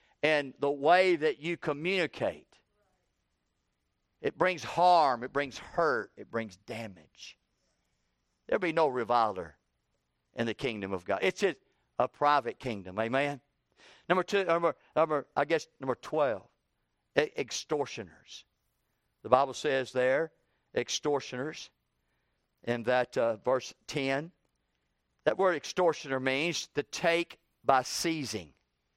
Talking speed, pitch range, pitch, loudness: 115 wpm, 110-160 Hz, 135 Hz, -30 LUFS